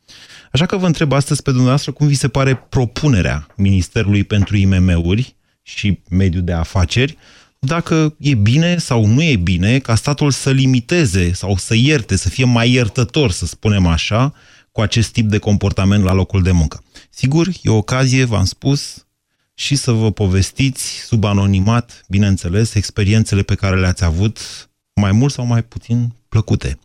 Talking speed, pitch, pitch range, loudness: 165 wpm, 110 Hz, 95-130 Hz, -15 LUFS